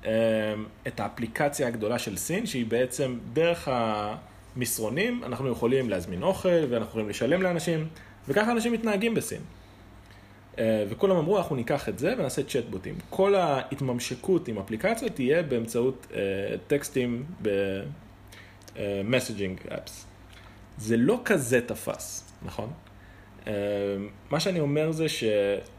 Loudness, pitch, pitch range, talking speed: -28 LUFS, 115 Hz, 100-150 Hz, 110 wpm